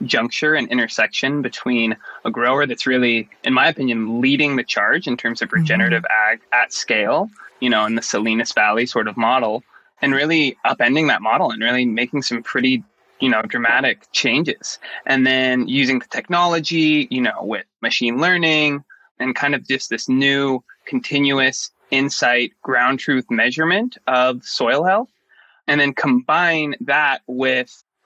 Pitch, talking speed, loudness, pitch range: 130 Hz, 155 wpm, -18 LUFS, 125-150 Hz